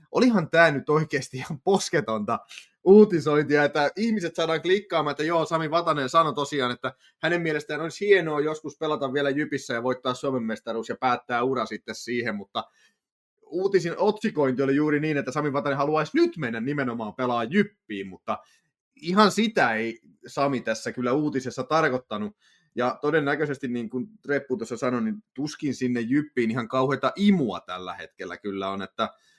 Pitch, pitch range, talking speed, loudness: 145 Hz, 125-165 Hz, 160 wpm, -25 LUFS